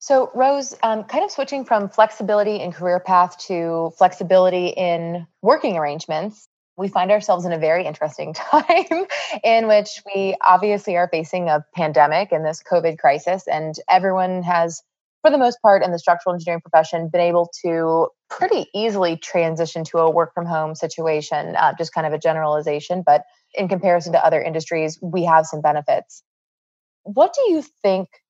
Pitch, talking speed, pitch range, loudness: 180 Hz, 170 wpm, 165-210 Hz, -19 LUFS